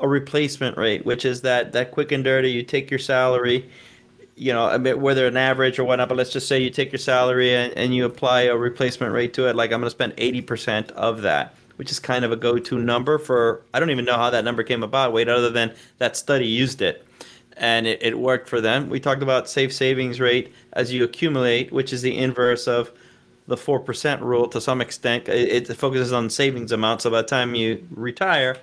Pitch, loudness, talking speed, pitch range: 125 Hz, -21 LUFS, 235 wpm, 120-130 Hz